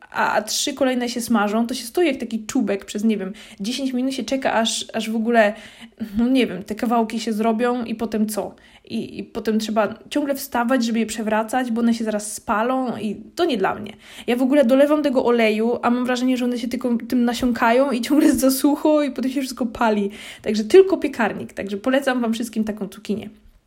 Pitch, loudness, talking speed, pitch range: 235 Hz, -21 LUFS, 210 wpm, 220-255 Hz